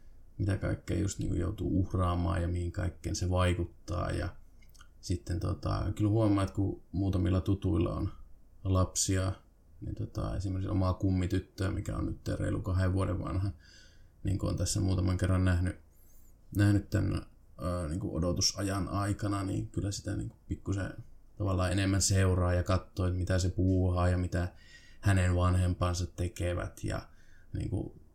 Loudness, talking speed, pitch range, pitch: -32 LUFS, 145 wpm, 90-100 Hz, 95 Hz